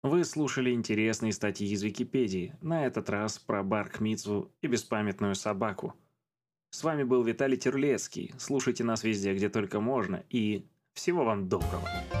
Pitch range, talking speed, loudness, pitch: 105-135 Hz, 150 wpm, -31 LUFS, 115 Hz